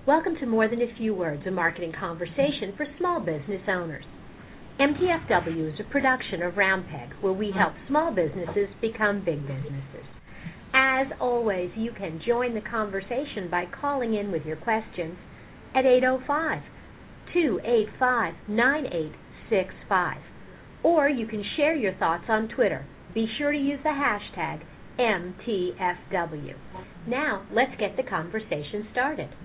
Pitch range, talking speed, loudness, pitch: 180-260 Hz, 130 wpm, -26 LUFS, 220 Hz